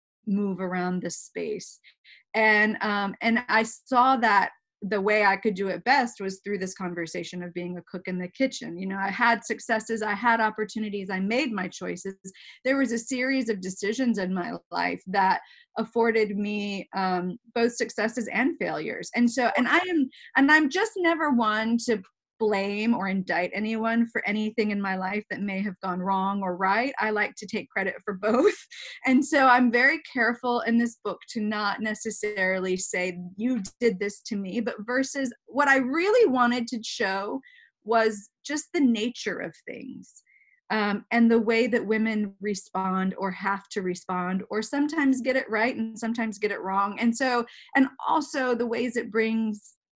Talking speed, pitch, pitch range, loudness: 180 wpm, 220 Hz, 195-245 Hz, -26 LUFS